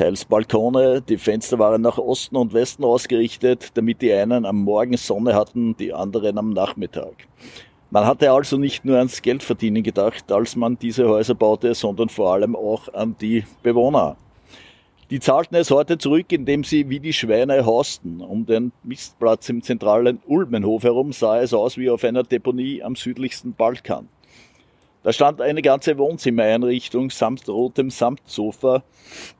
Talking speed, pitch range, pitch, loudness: 155 wpm, 110-130 Hz, 120 Hz, -20 LUFS